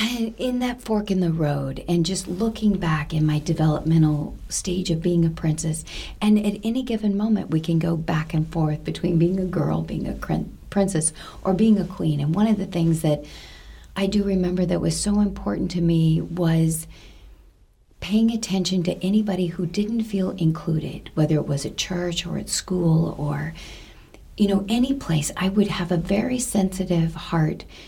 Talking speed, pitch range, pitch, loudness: 180 wpm, 160-200 Hz, 175 Hz, -23 LUFS